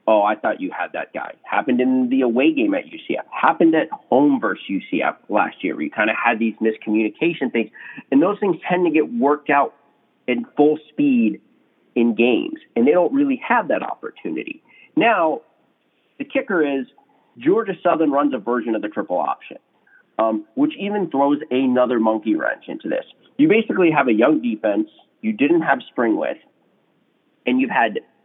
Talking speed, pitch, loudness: 180 wpm, 180 Hz, -20 LUFS